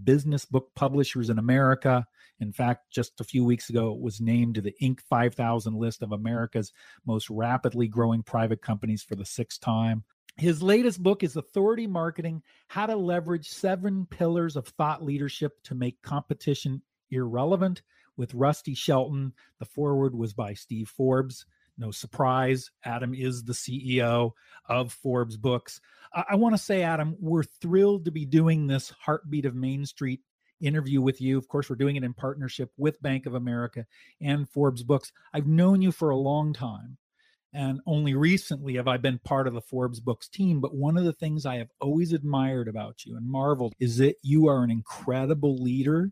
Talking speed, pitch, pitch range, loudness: 180 wpm, 135 Hz, 120-155 Hz, -27 LUFS